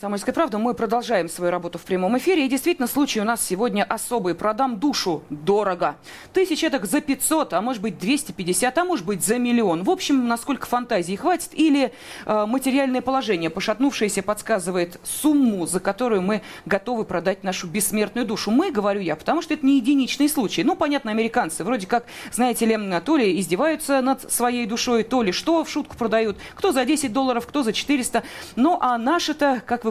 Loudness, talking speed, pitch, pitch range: -22 LUFS, 185 wpm, 240 Hz, 210-280 Hz